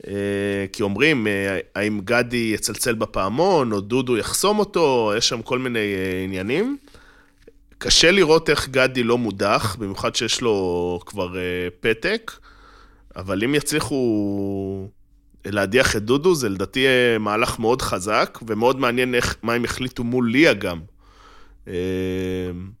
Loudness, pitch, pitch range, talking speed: -20 LUFS, 105 Hz, 95-125 Hz, 120 wpm